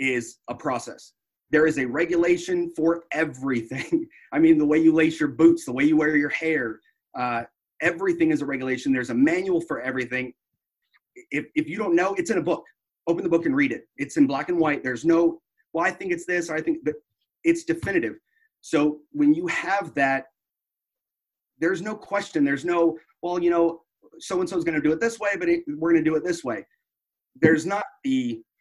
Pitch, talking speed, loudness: 170 Hz, 210 wpm, -24 LUFS